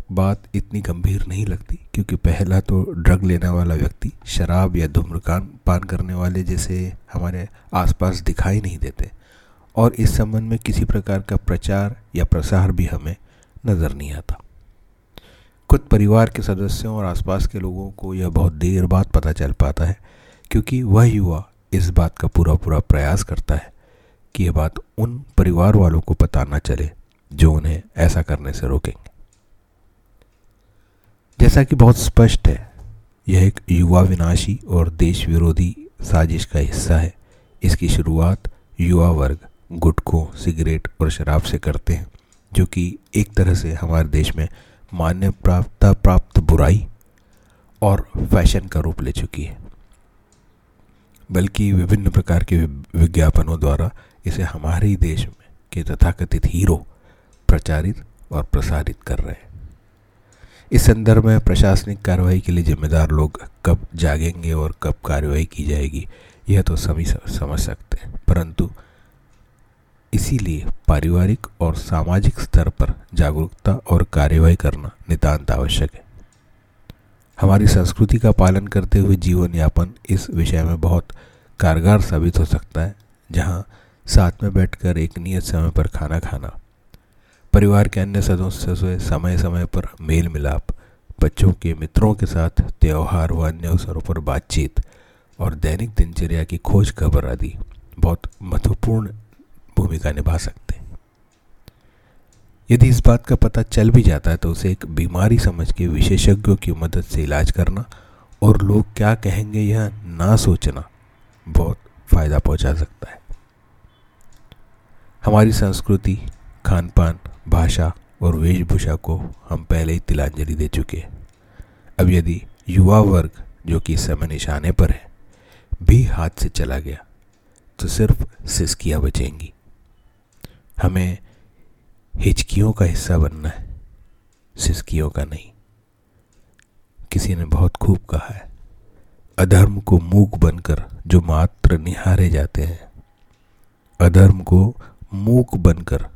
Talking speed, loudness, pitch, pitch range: 140 wpm, -18 LUFS, 90 Hz, 80-100 Hz